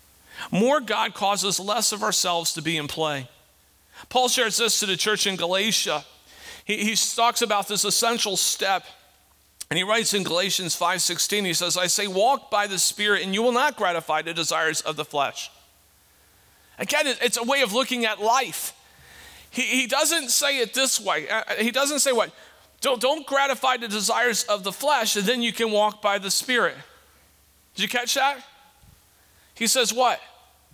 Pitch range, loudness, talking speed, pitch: 180-245 Hz, -22 LUFS, 180 wpm, 210 Hz